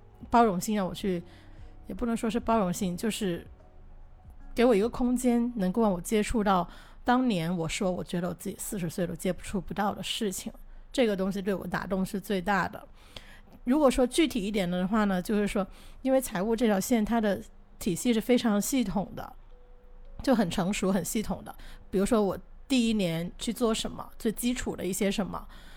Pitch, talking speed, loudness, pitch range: 205 Hz, 275 characters per minute, -29 LUFS, 185-230 Hz